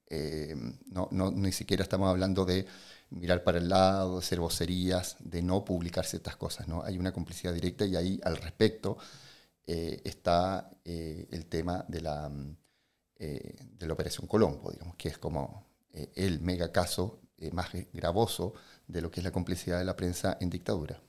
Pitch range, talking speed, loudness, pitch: 85-95 Hz, 180 wpm, -33 LUFS, 90 Hz